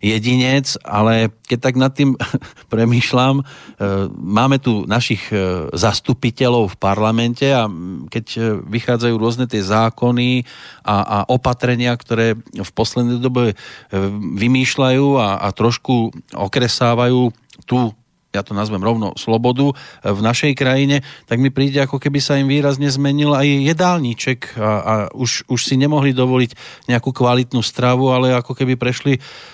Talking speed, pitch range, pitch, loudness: 130 wpm, 110-130 Hz, 125 Hz, -17 LUFS